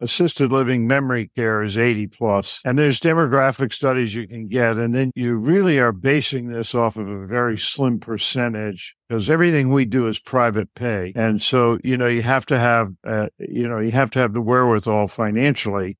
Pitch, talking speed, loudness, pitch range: 120 Hz, 195 wpm, -19 LUFS, 110-130 Hz